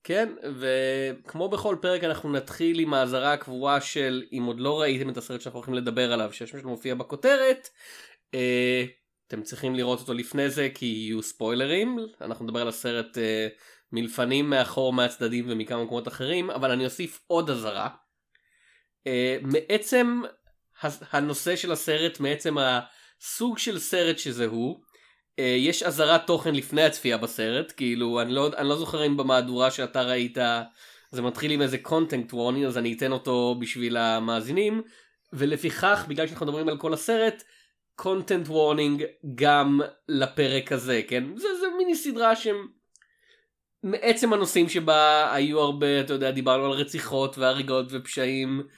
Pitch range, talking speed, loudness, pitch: 125-165 Hz, 140 wpm, -26 LUFS, 140 Hz